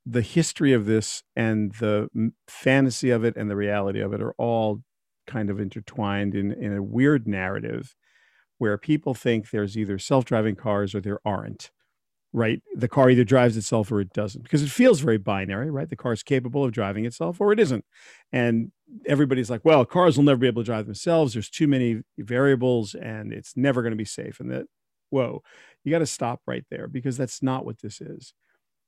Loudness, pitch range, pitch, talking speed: -24 LUFS, 105-135 Hz, 120 Hz, 205 wpm